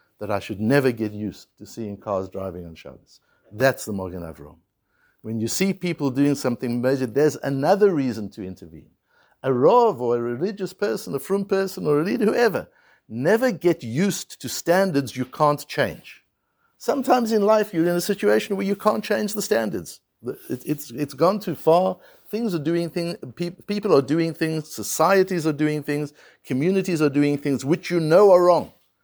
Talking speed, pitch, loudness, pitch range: 180 wpm, 150 Hz, -22 LUFS, 120-190 Hz